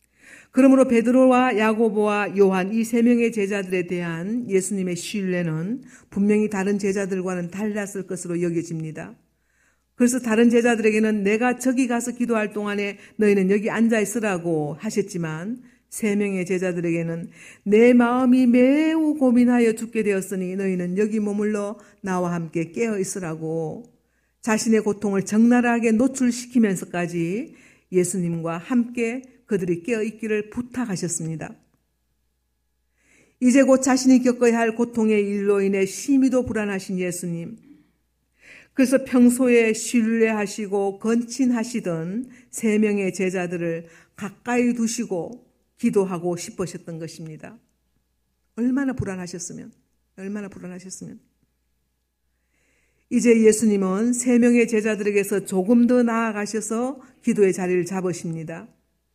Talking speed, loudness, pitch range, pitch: 295 characters per minute, -21 LUFS, 185-235 Hz, 210 Hz